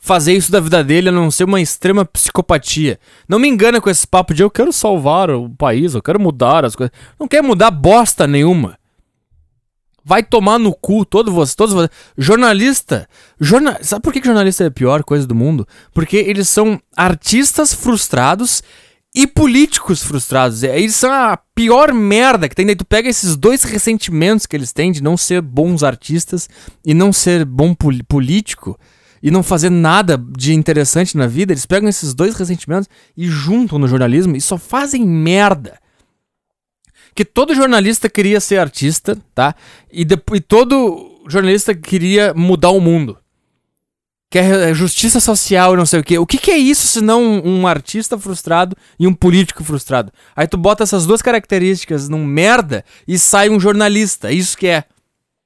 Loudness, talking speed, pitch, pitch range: -12 LUFS, 175 wpm, 185 Hz, 155-215 Hz